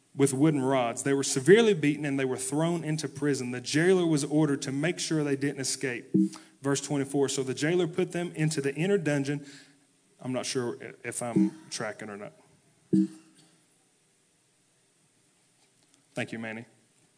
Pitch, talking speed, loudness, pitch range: 140 Hz, 155 wpm, -28 LUFS, 135-155 Hz